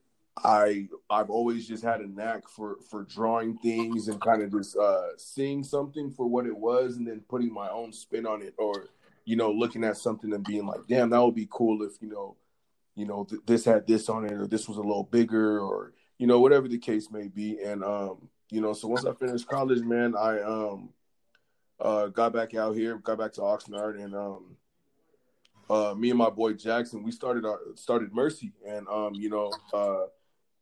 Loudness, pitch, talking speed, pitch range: -28 LUFS, 110 Hz, 210 wpm, 105-120 Hz